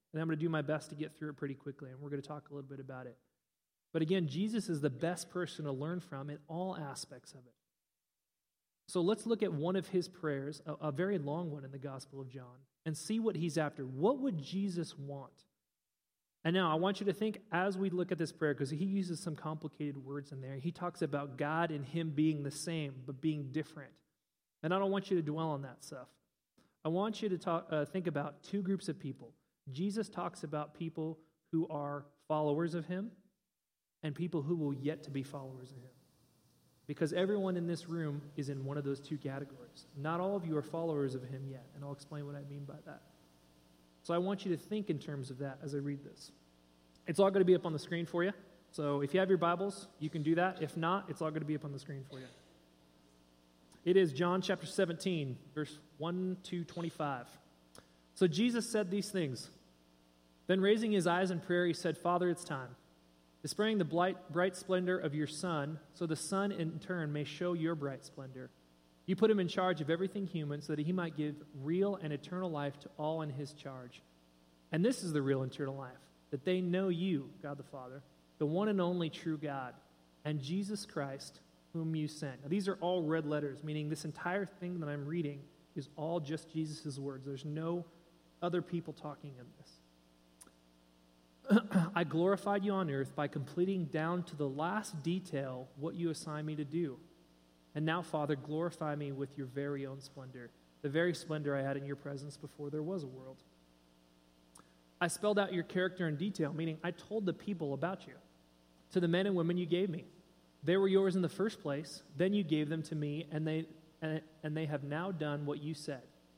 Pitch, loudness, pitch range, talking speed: 155 Hz, -37 LUFS, 140-175 Hz, 215 wpm